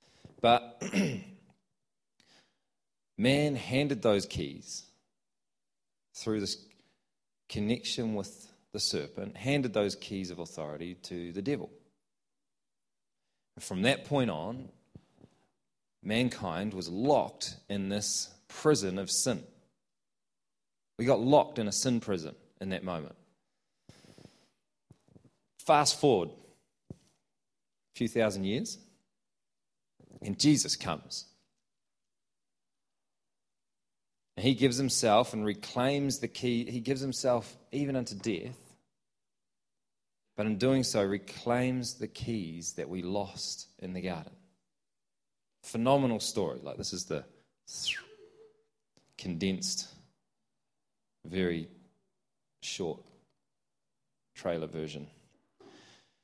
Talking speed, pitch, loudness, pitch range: 95 wpm, 115 Hz, -32 LUFS, 100-130 Hz